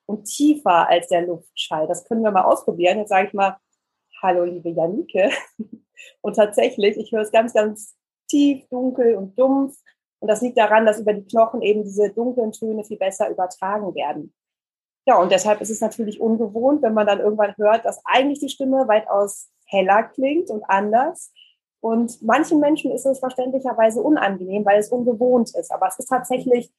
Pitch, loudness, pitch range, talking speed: 220 Hz, -20 LUFS, 200-250 Hz, 180 wpm